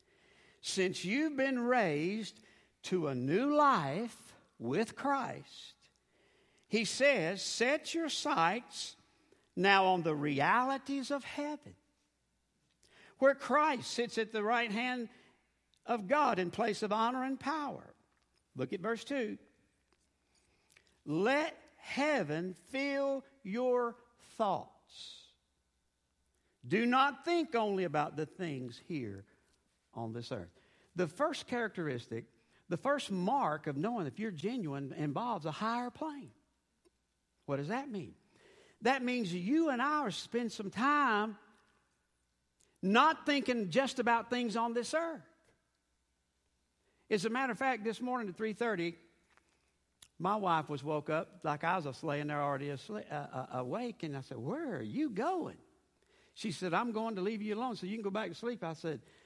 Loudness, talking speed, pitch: -35 LUFS, 140 wpm, 215 Hz